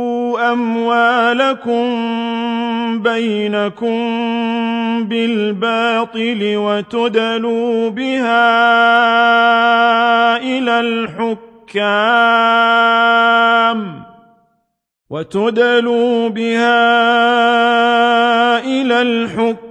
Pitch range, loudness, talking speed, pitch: 230-235 Hz, -14 LUFS, 35 wpm, 230 Hz